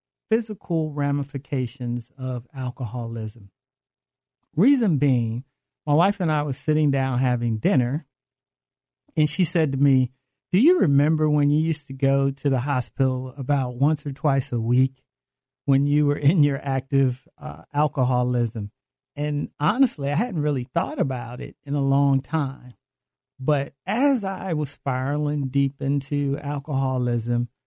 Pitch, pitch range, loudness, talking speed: 135 Hz, 130-150 Hz, -23 LUFS, 140 wpm